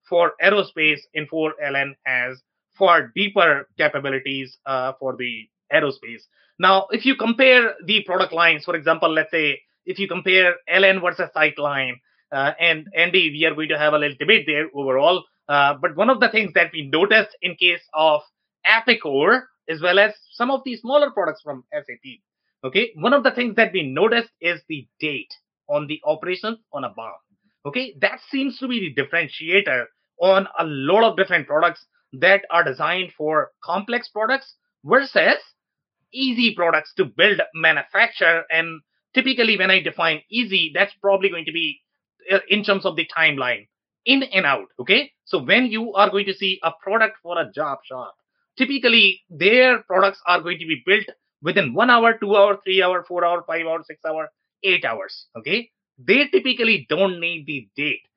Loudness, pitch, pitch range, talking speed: -19 LUFS, 180 Hz, 155-220 Hz, 175 wpm